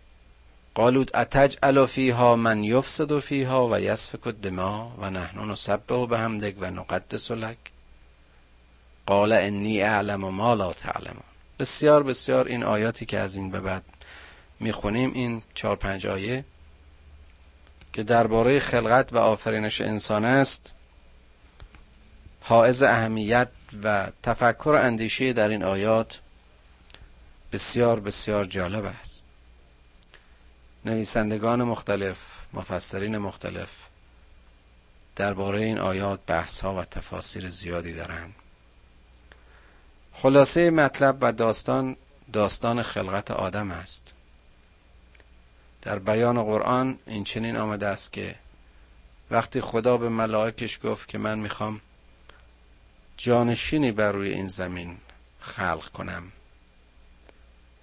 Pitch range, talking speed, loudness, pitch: 70-115 Hz, 110 wpm, -25 LUFS, 100 Hz